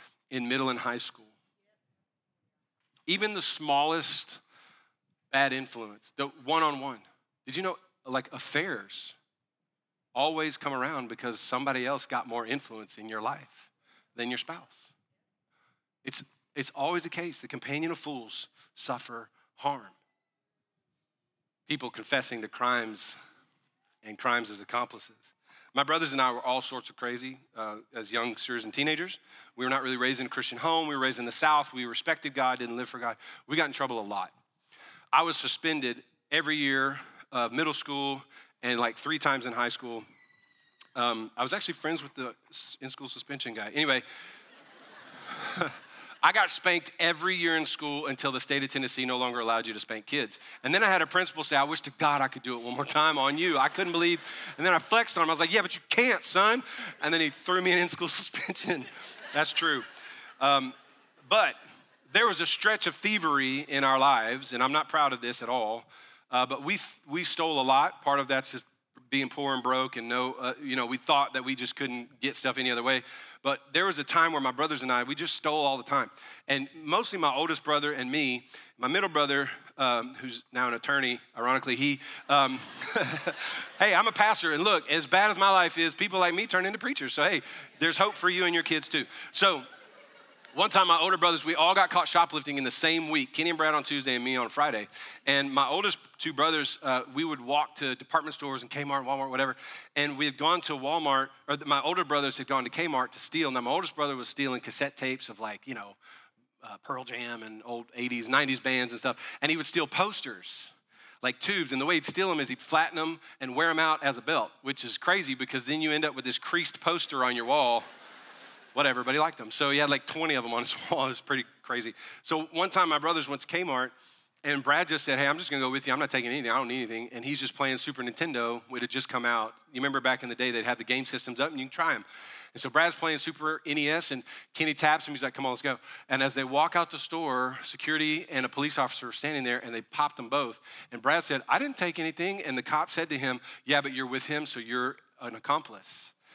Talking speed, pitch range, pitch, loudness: 225 wpm, 125-155 Hz, 140 Hz, -28 LUFS